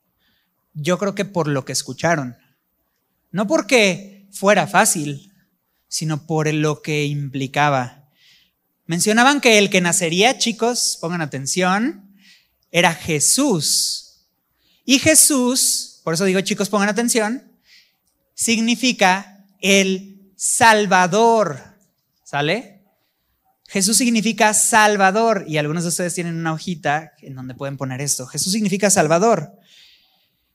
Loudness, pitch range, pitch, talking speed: -17 LUFS, 150-215 Hz, 185 Hz, 110 wpm